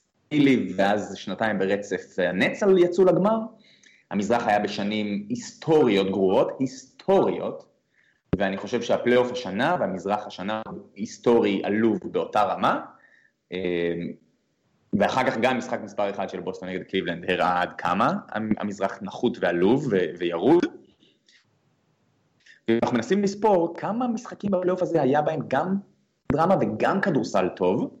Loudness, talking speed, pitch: -24 LUFS, 115 wpm, 115 Hz